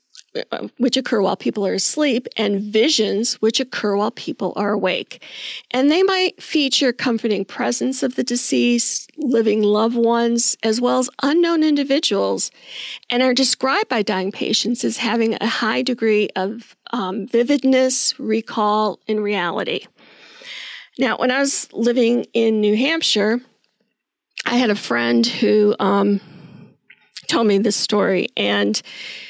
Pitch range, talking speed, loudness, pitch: 210-255 Hz, 135 wpm, -18 LUFS, 225 Hz